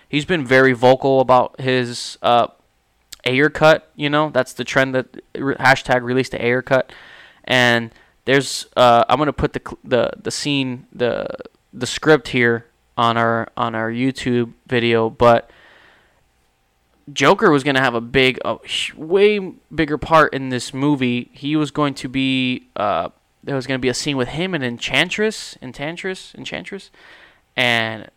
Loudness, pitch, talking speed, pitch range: -18 LUFS, 130 Hz, 160 wpm, 120-145 Hz